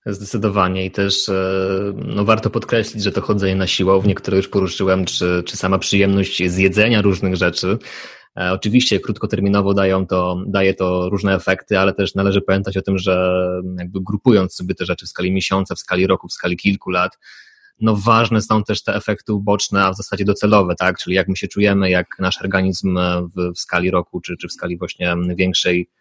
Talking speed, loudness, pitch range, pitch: 185 wpm, -18 LUFS, 90-100 Hz, 95 Hz